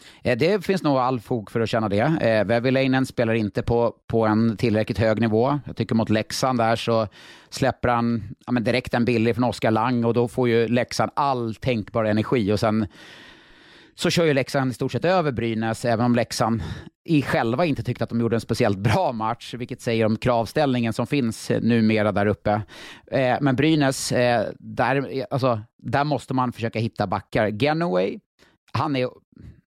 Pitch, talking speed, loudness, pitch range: 120 Hz, 185 wpm, -22 LUFS, 110-130 Hz